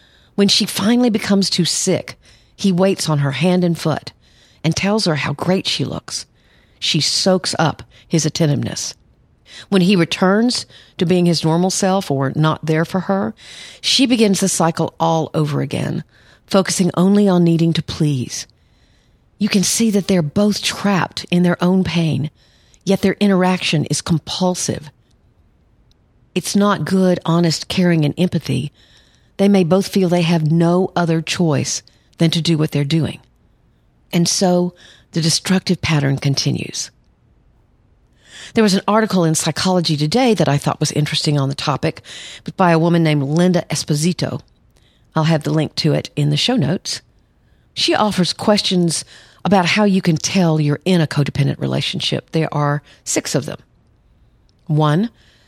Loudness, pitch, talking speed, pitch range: -17 LUFS, 165 Hz, 160 wpm, 150-185 Hz